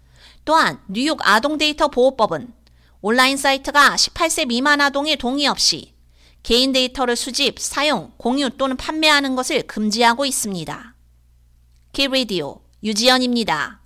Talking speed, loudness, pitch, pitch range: 250 characters per minute, -17 LUFS, 255 Hz, 210-280 Hz